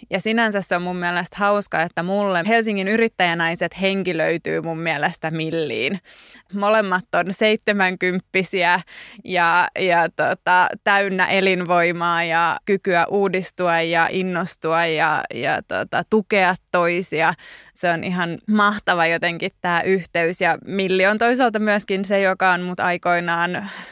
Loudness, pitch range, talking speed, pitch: -19 LUFS, 170-200 Hz, 130 wpm, 180 Hz